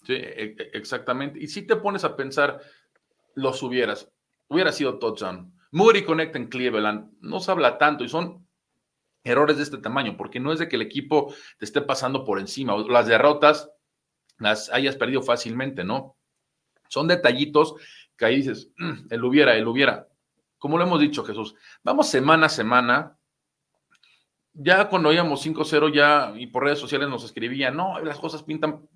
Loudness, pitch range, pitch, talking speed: -22 LUFS, 130-160 Hz, 145 Hz, 165 wpm